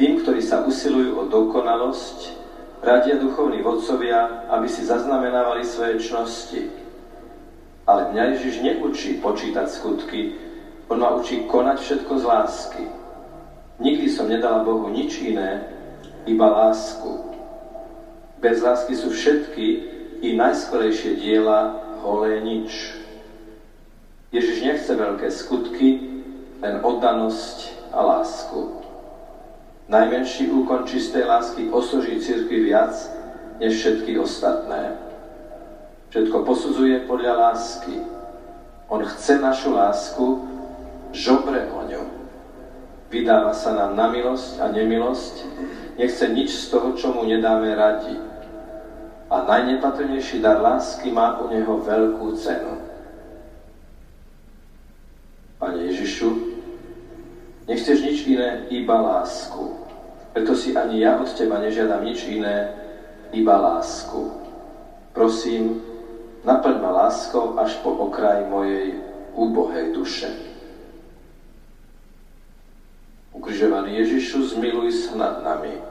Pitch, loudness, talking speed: 135 Hz, -21 LUFS, 105 wpm